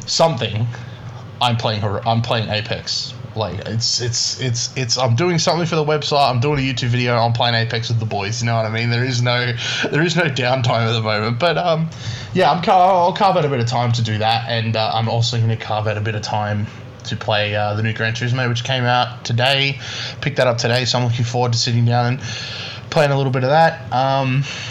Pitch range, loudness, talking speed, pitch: 115-130 Hz, -18 LUFS, 245 wpm, 120 Hz